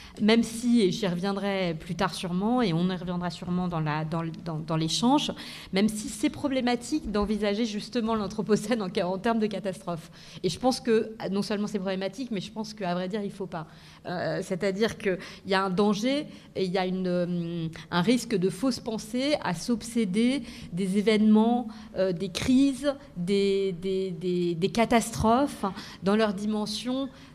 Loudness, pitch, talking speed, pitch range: -28 LUFS, 200 Hz, 170 wpm, 185-230 Hz